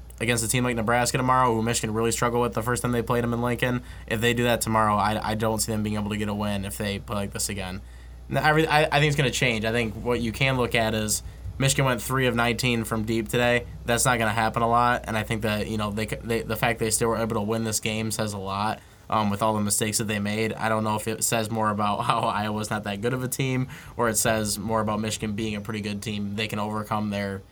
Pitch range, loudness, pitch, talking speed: 105-120 Hz, -25 LUFS, 110 Hz, 290 wpm